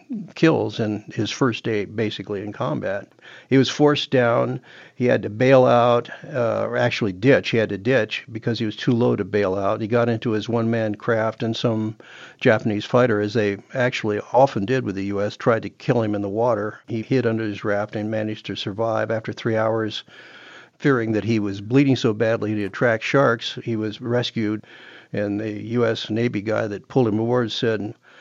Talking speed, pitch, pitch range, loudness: 200 wpm, 115 Hz, 105-125 Hz, -21 LUFS